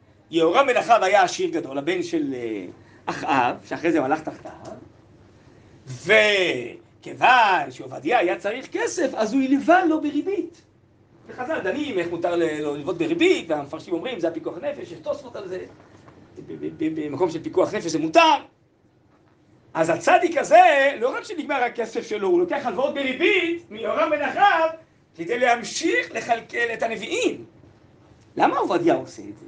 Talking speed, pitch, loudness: 145 wpm, 275 Hz, -21 LUFS